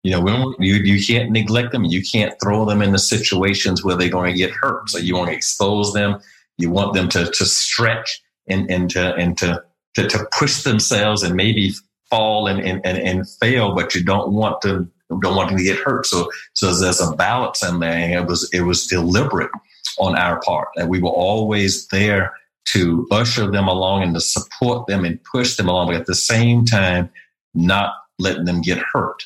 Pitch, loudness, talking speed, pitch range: 95 Hz, -18 LUFS, 215 wpm, 90-105 Hz